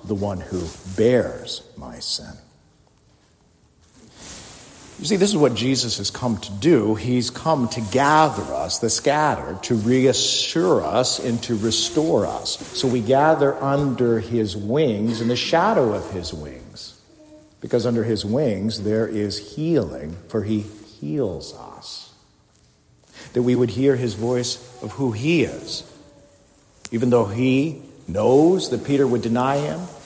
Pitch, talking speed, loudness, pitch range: 120 Hz, 145 wpm, -21 LUFS, 105-135 Hz